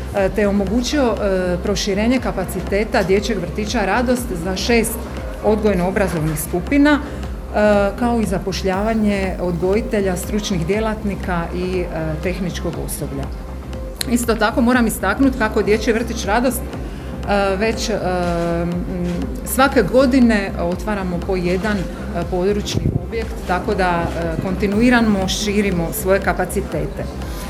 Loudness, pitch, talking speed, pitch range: -19 LUFS, 195 Hz, 110 wpm, 180-215 Hz